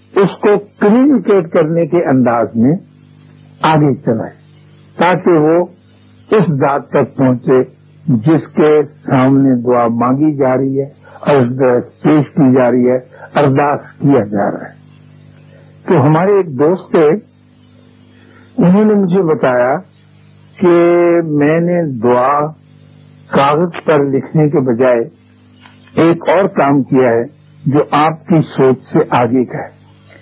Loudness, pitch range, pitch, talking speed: -12 LUFS, 130-165 Hz, 145 Hz, 130 wpm